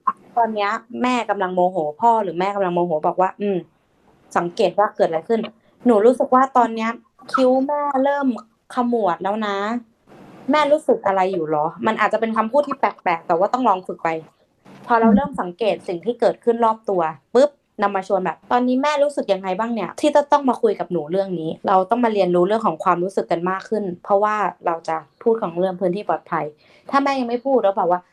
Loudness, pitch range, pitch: -20 LUFS, 180-240 Hz, 210 Hz